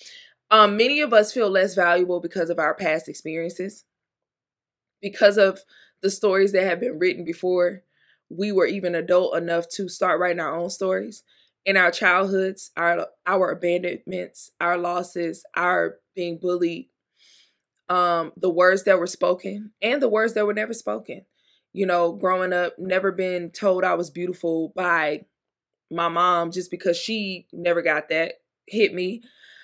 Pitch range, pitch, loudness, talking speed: 175-195 Hz, 180 Hz, -22 LUFS, 155 wpm